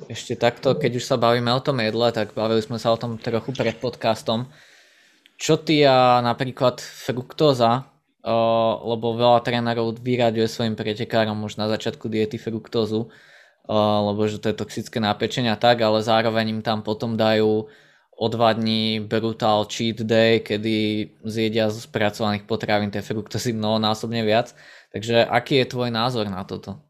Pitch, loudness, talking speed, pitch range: 115 Hz, -22 LUFS, 160 wpm, 110-120 Hz